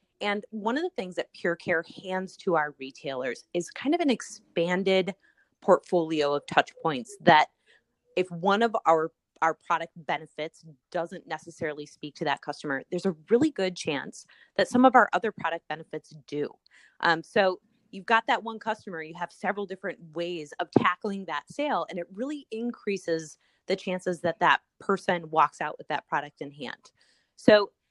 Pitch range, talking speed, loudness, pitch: 160-205 Hz, 175 wpm, -28 LUFS, 180 Hz